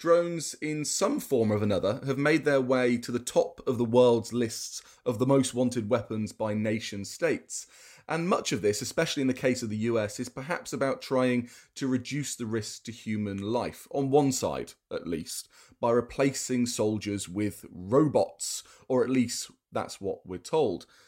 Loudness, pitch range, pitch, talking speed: -29 LUFS, 115-135 Hz, 125 Hz, 180 wpm